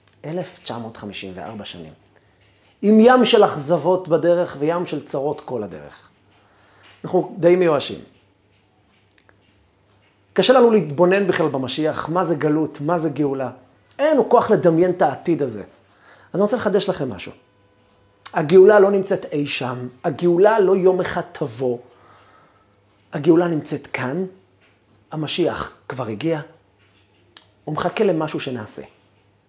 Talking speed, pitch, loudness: 120 wpm, 145 Hz, -19 LUFS